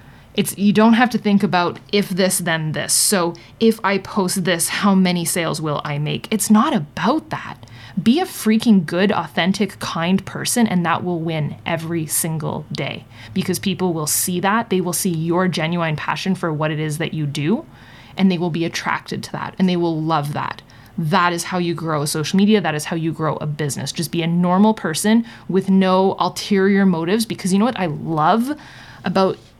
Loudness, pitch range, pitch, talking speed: -19 LUFS, 165-195 Hz, 180 Hz, 205 wpm